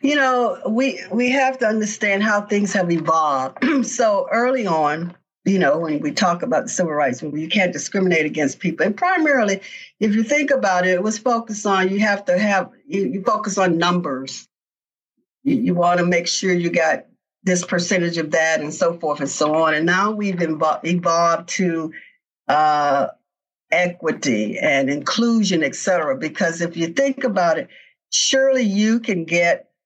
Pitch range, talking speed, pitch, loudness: 165-225 Hz, 175 wpm, 185 Hz, -19 LUFS